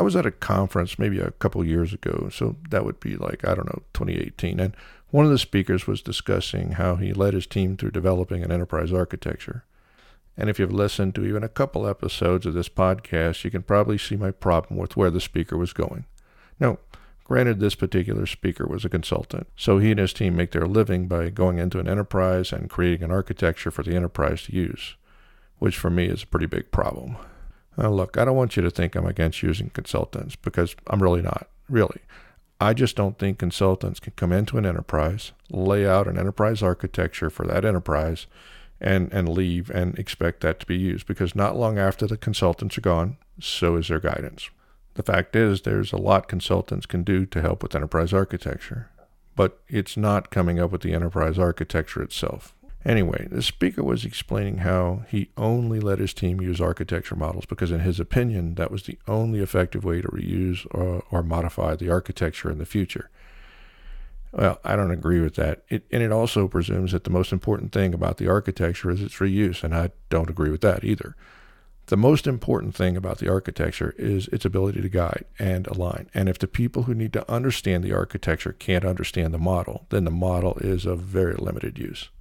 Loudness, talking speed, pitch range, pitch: -24 LUFS, 200 wpm, 85-100 Hz, 95 Hz